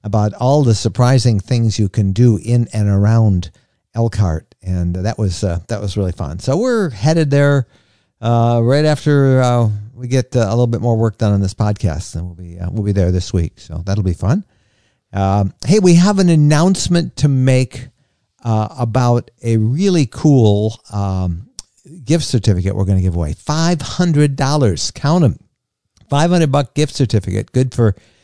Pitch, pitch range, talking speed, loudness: 115 Hz, 100-135 Hz, 180 wpm, -15 LUFS